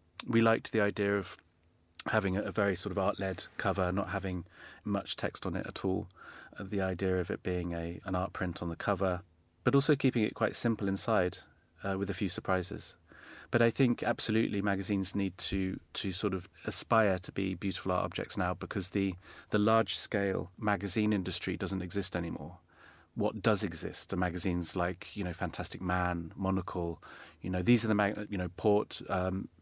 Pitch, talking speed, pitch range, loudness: 95 Hz, 185 wpm, 90-105 Hz, -32 LUFS